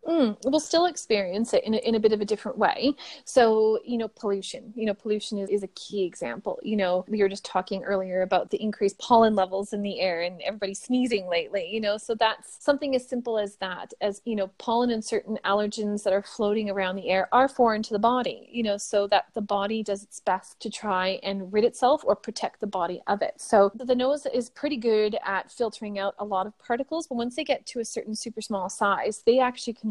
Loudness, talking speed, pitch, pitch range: -26 LUFS, 235 wpm, 215 Hz, 200-235 Hz